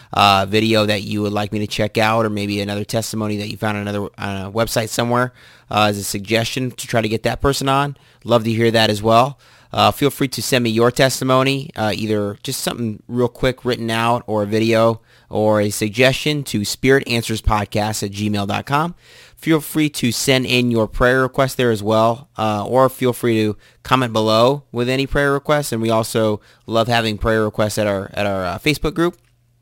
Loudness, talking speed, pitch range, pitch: -18 LUFS, 205 wpm, 105-130 Hz, 115 Hz